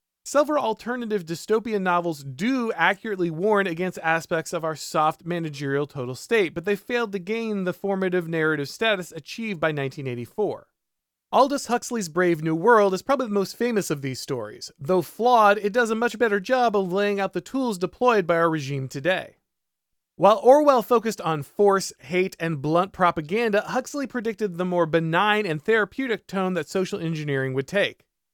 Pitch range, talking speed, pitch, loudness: 165-220 Hz, 170 wpm, 190 Hz, -23 LUFS